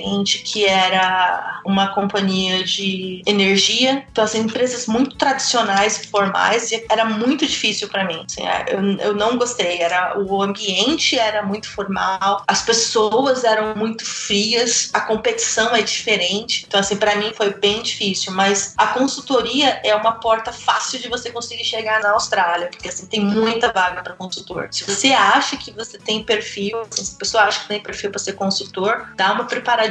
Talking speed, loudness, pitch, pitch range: 175 wpm, -18 LUFS, 210 Hz, 195-235 Hz